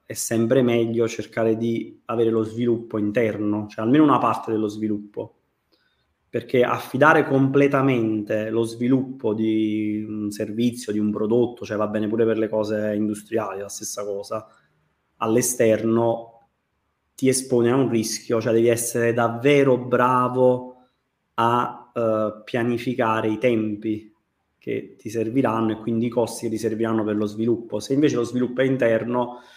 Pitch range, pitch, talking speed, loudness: 110-120 Hz, 115 Hz, 145 wpm, -22 LUFS